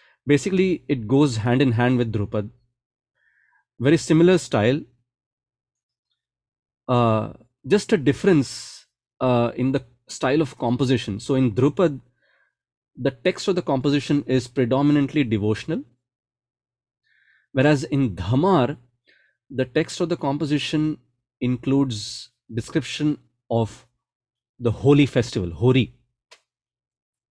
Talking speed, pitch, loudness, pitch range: 105 wpm, 130 Hz, -22 LUFS, 120-145 Hz